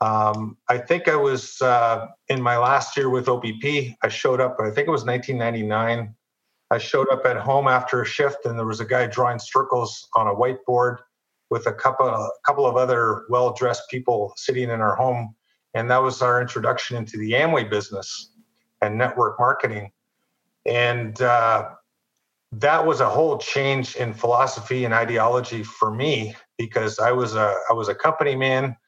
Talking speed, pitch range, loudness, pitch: 180 wpm, 115-130 Hz, -22 LUFS, 125 Hz